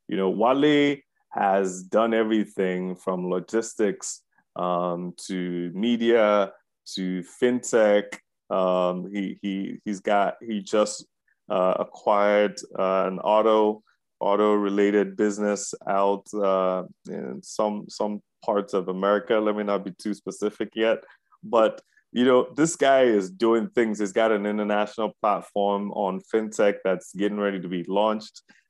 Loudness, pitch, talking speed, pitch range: -24 LUFS, 105 Hz, 130 wpm, 95-110 Hz